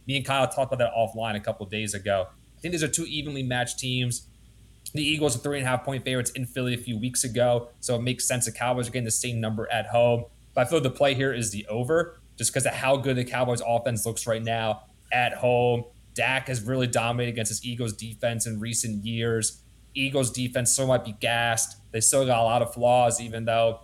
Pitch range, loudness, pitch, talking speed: 115-130 Hz, -26 LUFS, 120 Hz, 240 wpm